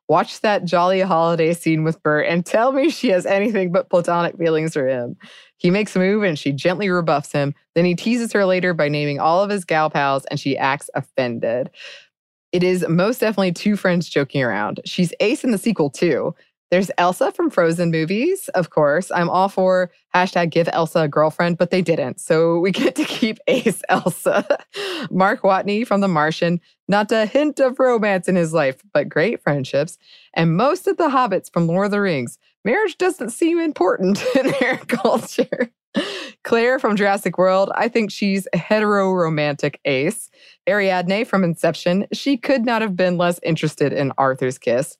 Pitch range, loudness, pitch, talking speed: 165-215 Hz, -19 LUFS, 185 Hz, 185 wpm